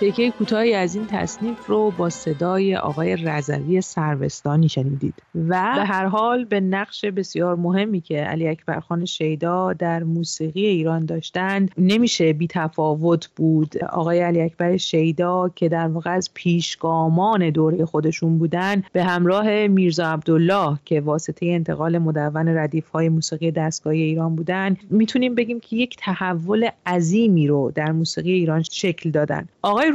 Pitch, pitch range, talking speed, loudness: 170 Hz, 160-190 Hz, 145 wpm, -21 LUFS